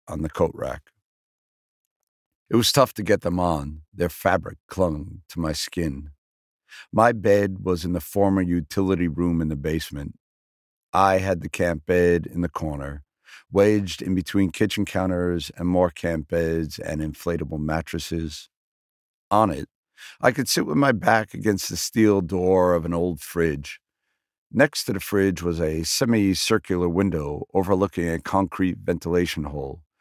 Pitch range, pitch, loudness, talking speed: 80-95 Hz, 85 Hz, -23 LUFS, 155 wpm